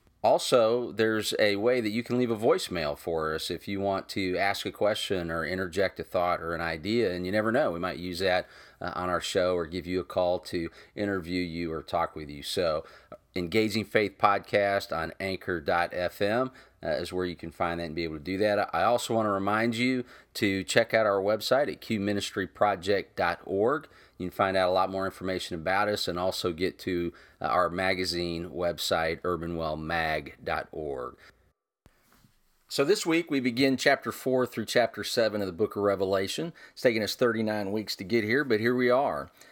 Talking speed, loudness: 190 wpm, -28 LUFS